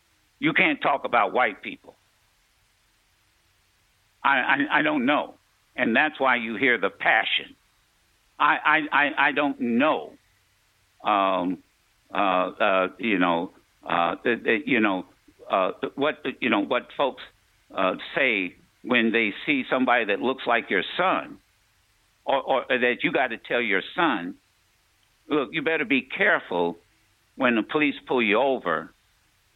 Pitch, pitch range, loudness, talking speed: 110 Hz, 100-130 Hz, -23 LUFS, 140 wpm